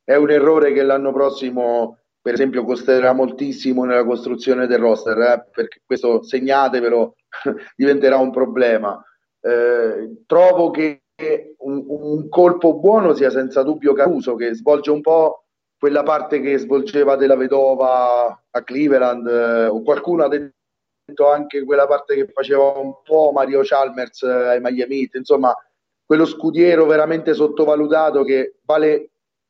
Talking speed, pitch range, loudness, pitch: 135 wpm, 130-150 Hz, -17 LUFS, 140 Hz